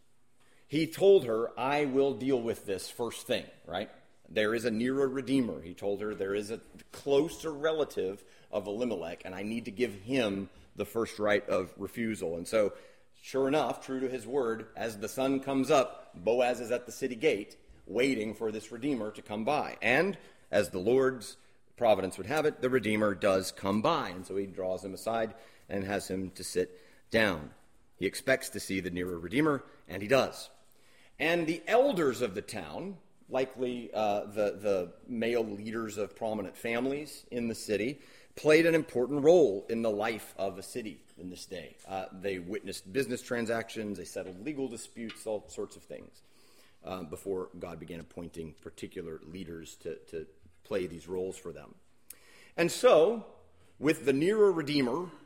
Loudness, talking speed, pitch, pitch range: -31 LUFS, 175 wpm, 115 Hz, 100-135 Hz